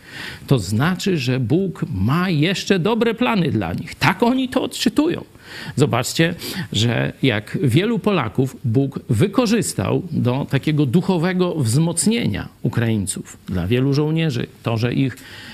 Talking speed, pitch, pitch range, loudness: 125 wpm, 150 Hz, 125-185 Hz, -19 LUFS